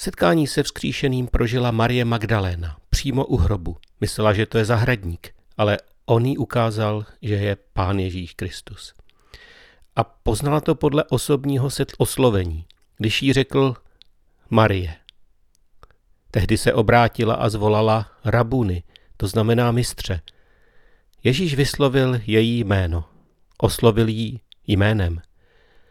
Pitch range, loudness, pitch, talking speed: 100-125 Hz, -21 LUFS, 115 Hz, 115 wpm